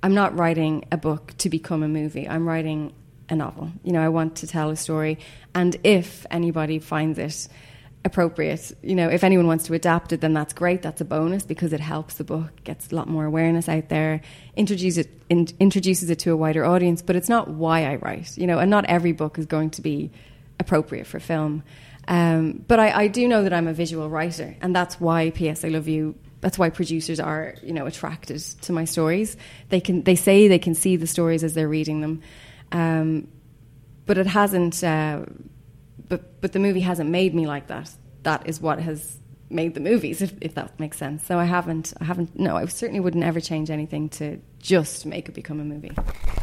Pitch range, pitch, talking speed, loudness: 155-175 Hz, 160 Hz, 215 wpm, -23 LUFS